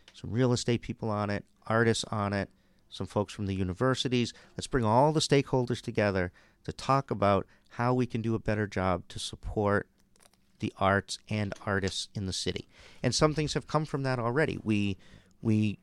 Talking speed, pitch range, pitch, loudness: 185 wpm, 100-125 Hz, 110 Hz, -30 LUFS